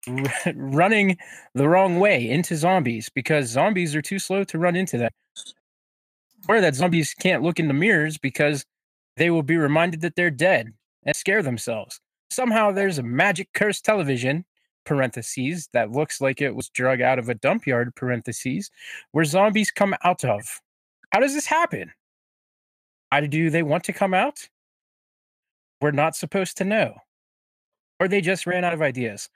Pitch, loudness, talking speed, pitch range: 165 Hz, -22 LUFS, 165 wpm, 135-190 Hz